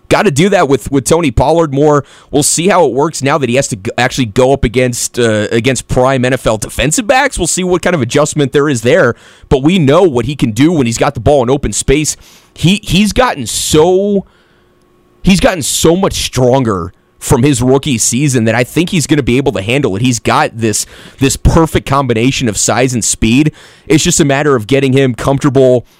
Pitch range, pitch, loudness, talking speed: 125-155 Hz, 135 Hz, -11 LUFS, 220 wpm